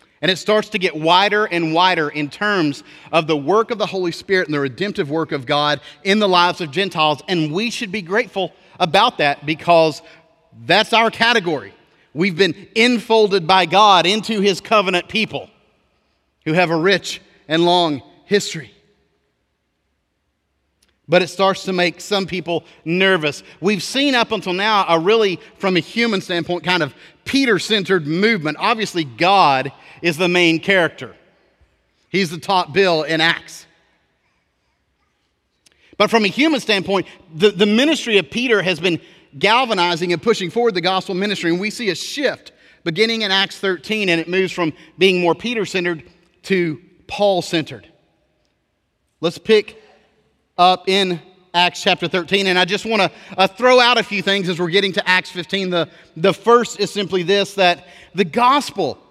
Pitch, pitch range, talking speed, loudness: 185 Hz, 165-205 Hz, 165 wpm, -17 LUFS